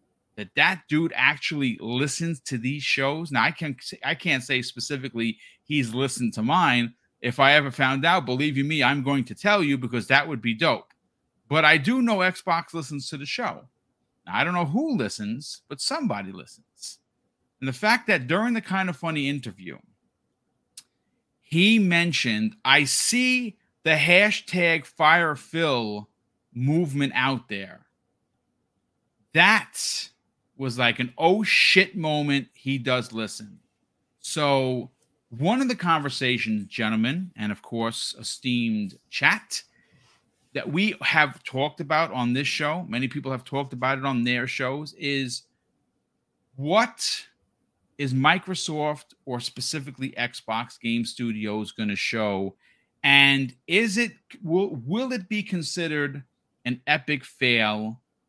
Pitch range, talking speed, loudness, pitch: 120-165 Hz, 140 wpm, -23 LUFS, 140 Hz